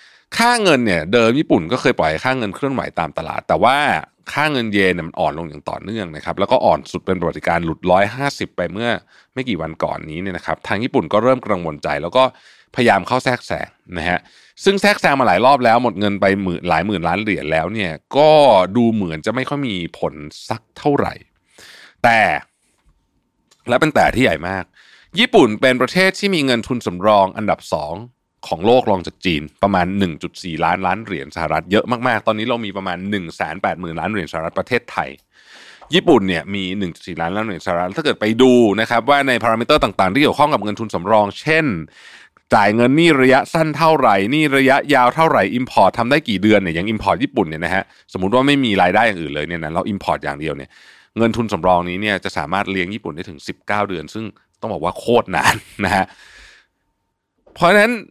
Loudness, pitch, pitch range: -17 LUFS, 105 Hz, 90-130 Hz